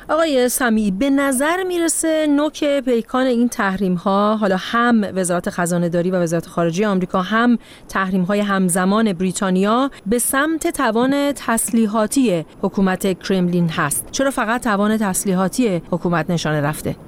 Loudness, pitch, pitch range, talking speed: -18 LUFS, 205 Hz, 185-250 Hz, 135 wpm